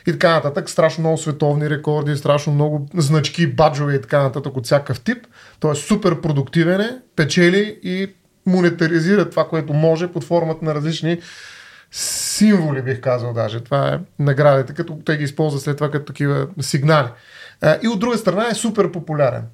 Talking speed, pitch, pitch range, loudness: 170 wpm, 160 Hz, 145-175 Hz, -18 LUFS